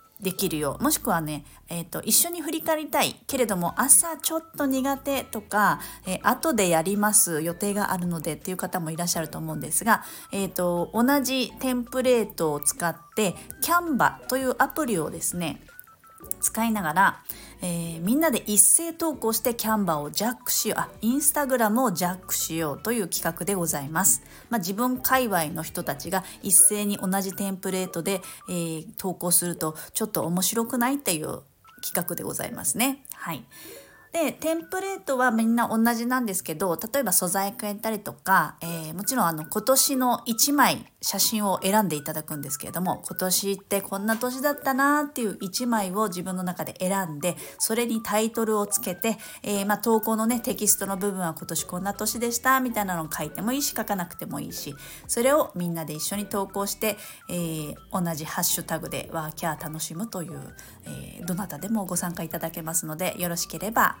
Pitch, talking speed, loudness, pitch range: 205 Hz, 370 characters per minute, -25 LUFS, 175-245 Hz